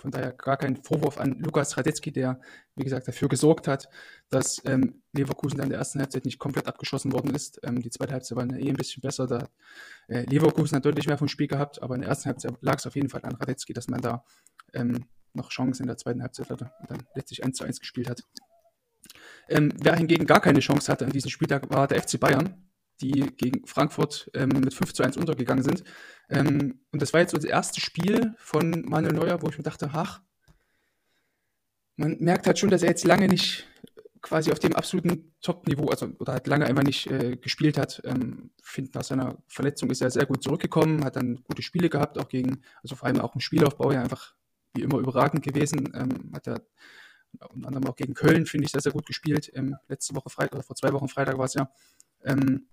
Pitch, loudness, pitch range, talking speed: 140 Hz, -26 LUFS, 130-155 Hz, 220 wpm